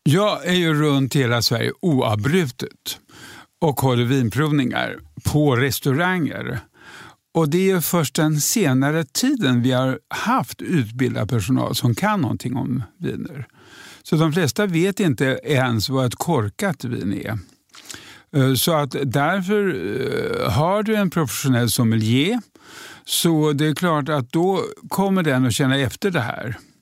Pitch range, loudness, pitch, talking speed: 130-175 Hz, -20 LUFS, 145 Hz, 140 wpm